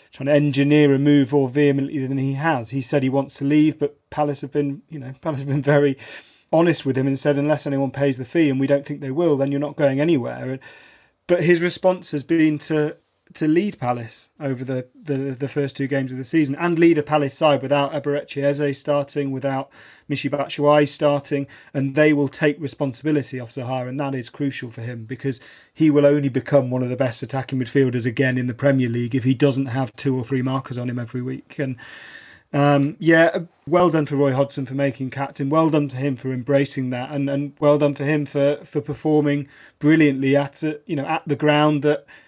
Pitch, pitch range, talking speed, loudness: 140 Hz, 135-150 Hz, 215 wpm, -21 LUFS